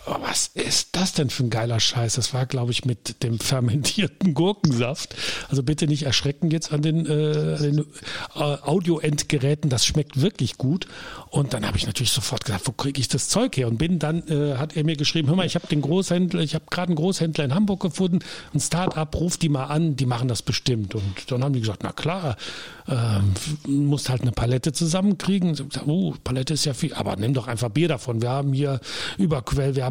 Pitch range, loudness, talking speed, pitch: 125-160 Hz, -23 LUFS, 215 wpm, 145 Hz